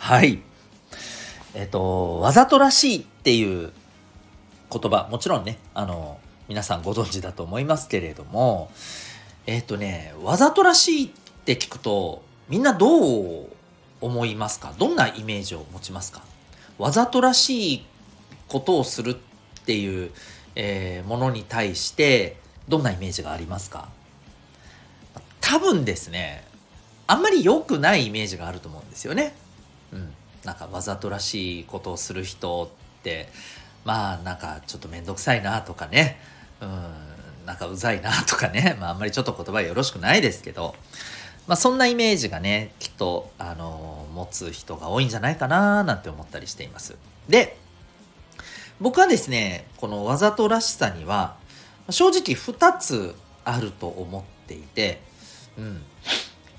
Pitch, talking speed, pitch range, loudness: 100 Hz, 300 characters per minute, 90-125 Hz, -22 LUFS